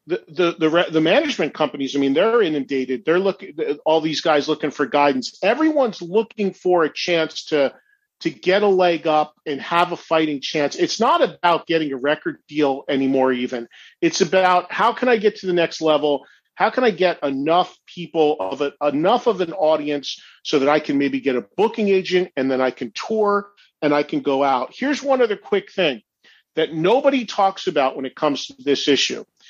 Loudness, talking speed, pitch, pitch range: -20 LUFS, 200 wpm, 160 Hz, 145-195 Hz